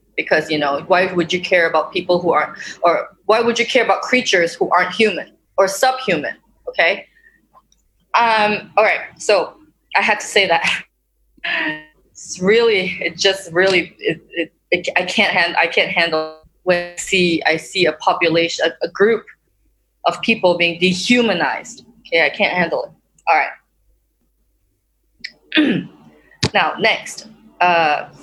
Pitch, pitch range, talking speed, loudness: 180 Hz, 170-225 Hz, 155 wpm, -16 LUFS